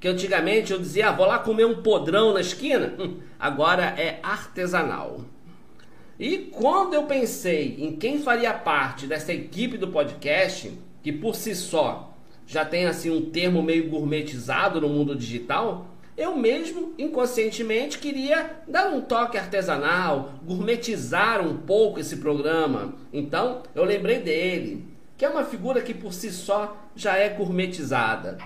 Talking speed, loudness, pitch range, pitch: 150 wpm, -24 LUFS, 160-240 Hz, 205 Hz